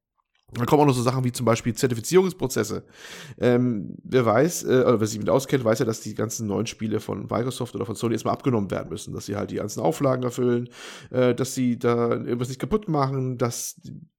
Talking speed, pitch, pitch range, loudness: 215 wpm, 125 Hz, 115-130 Hz, -24 LUFS